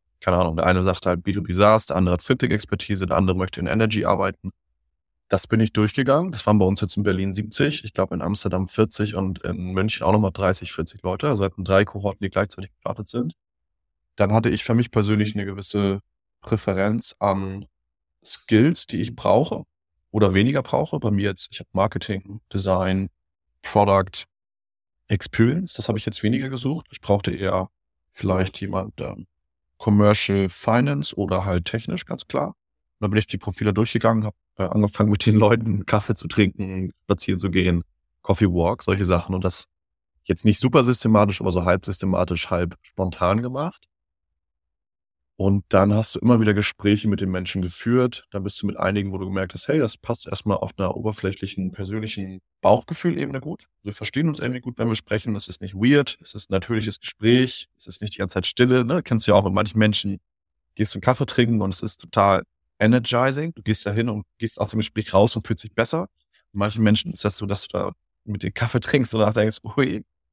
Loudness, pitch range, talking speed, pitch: -22 LUFS, 90-110 Hz, 200 wpm, 100 Hz